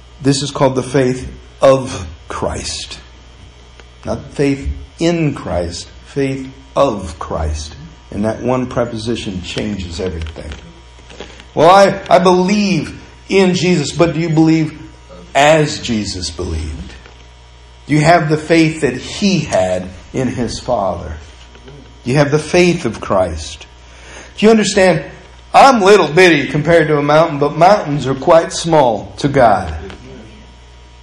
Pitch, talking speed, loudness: 125 Hz, 130 wpm, -14 LUFS